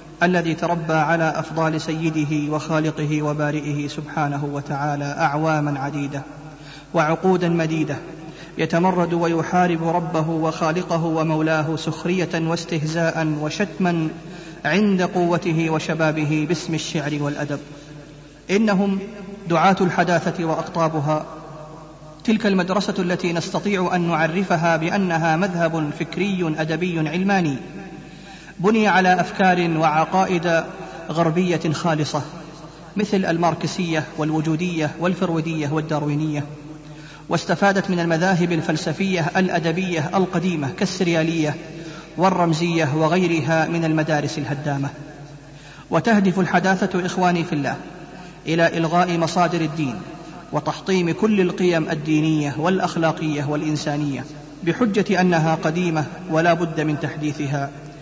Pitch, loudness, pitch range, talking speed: 165 Hz, -21 LUFS, 155-175 Hz, 90 wpm